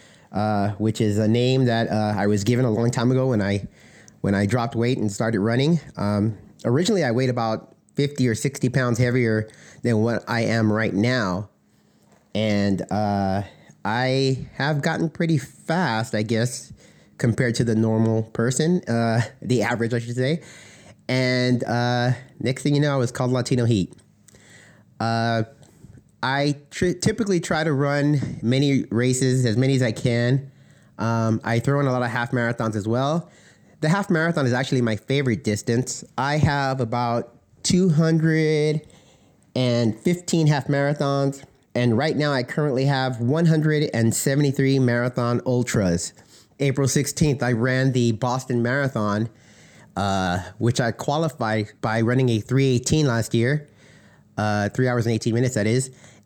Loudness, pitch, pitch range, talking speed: -22 LUFS, 125 Hz, 110-140 Hz, 155 wpm